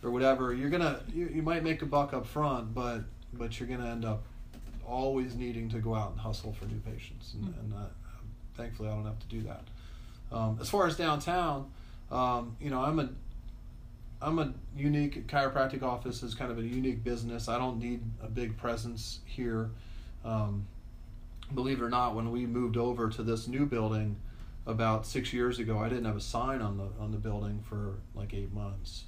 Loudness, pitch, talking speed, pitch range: -34 LUFS, 115 Hz, 205 wpm, 110-125 Hz